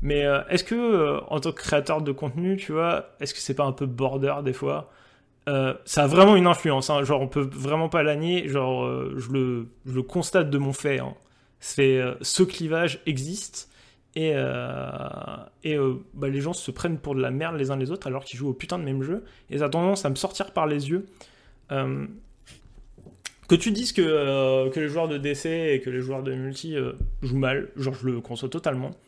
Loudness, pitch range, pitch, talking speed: -25 LUFS, 130-165 Hz, 140 Hz, 230 wpm